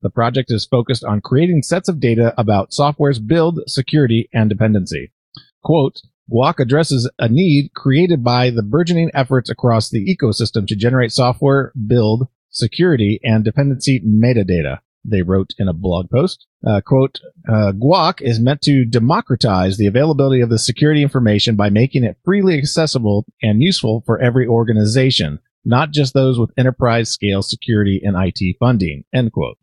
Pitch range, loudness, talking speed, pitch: 110-140 Hz, -15 LUFS, 155 wpm, 120 Hz